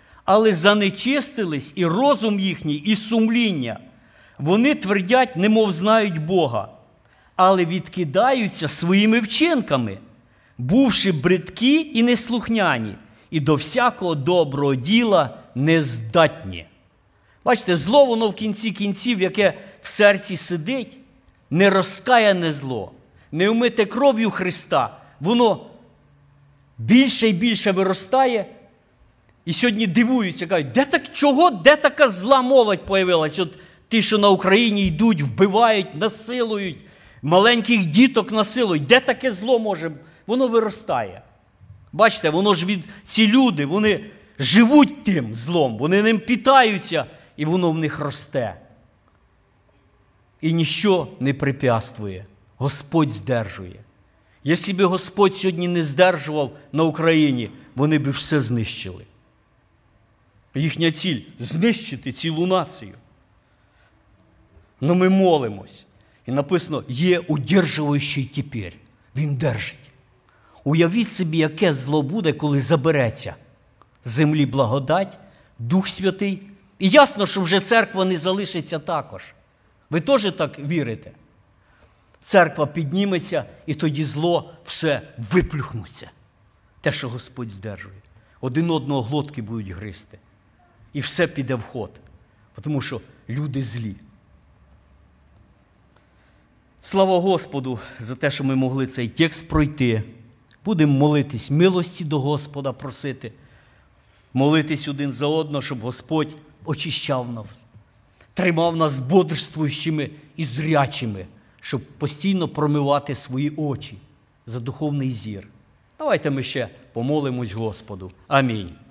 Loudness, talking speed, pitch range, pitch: -20 LUFS, 110 wpm, 125-195 Hz, 155 Hz